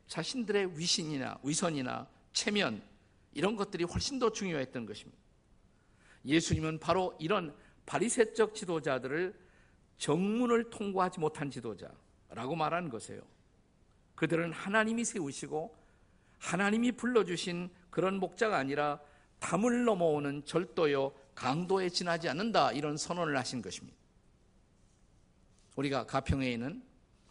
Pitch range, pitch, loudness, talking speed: 135-200 Hz, 165 Hz, -33 LUFS, 290 characters per minute